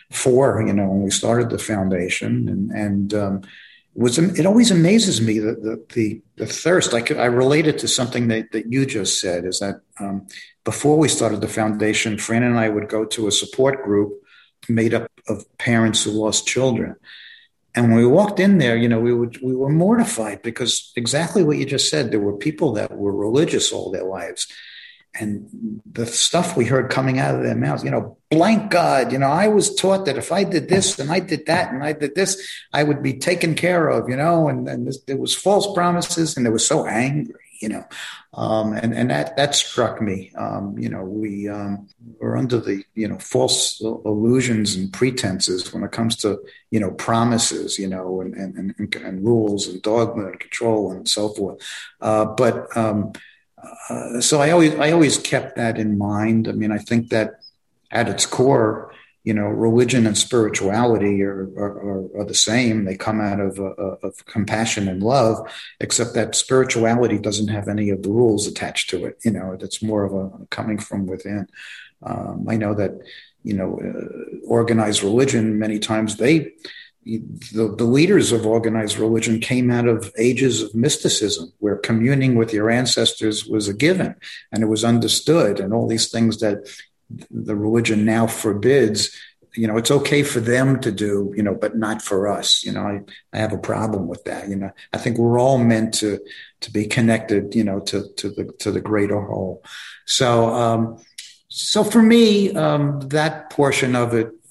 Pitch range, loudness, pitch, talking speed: 105-130 Hz, -19 LUFS, 115 Hz, 195 wpm